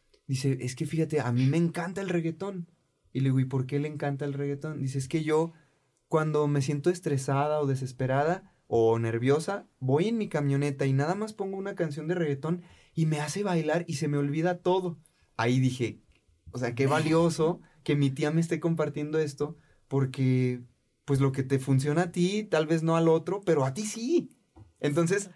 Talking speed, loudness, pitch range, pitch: 200 wpm, -28 LUFS, 135-170 Hz, 150 Hz